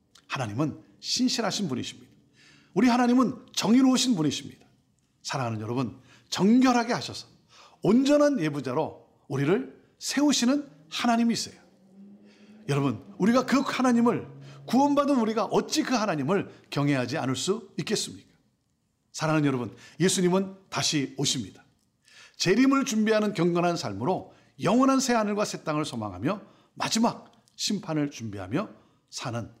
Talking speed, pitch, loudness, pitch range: 315 characters per minute, 190 Hz, -26 LUFS, 140-235 Hz